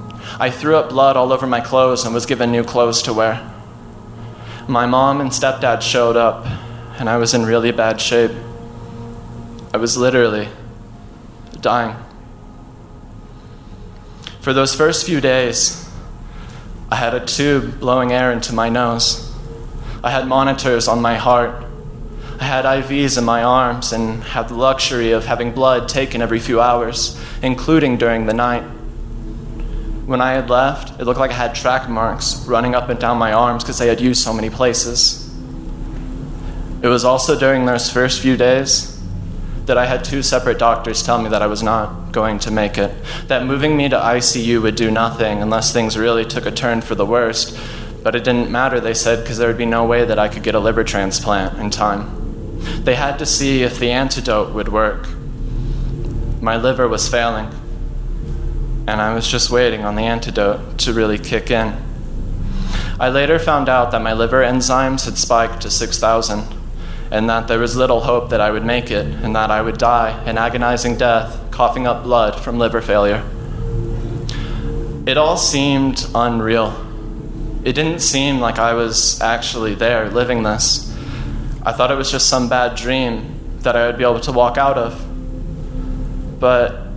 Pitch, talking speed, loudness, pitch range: 120 Hz, 175 wpm, -16 LUFS, 115-125 Hz